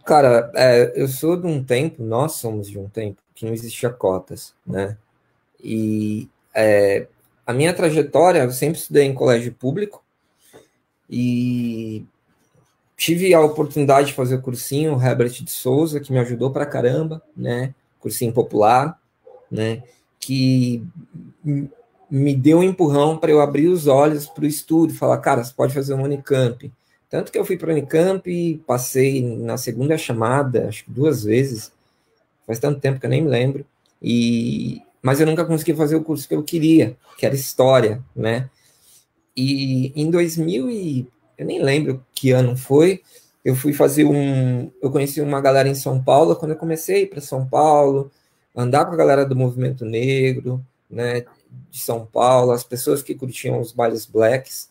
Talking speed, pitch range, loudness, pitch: 170 wpm, 120-150 Hz, -19 LUFS, 135 Hz